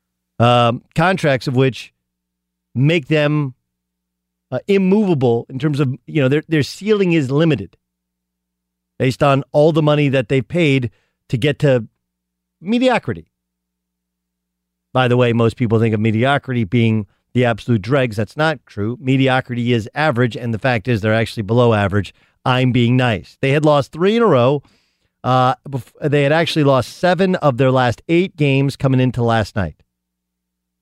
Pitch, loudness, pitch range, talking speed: 125 Hz, -16 LUFS, 95-145 Hz, 160 wpm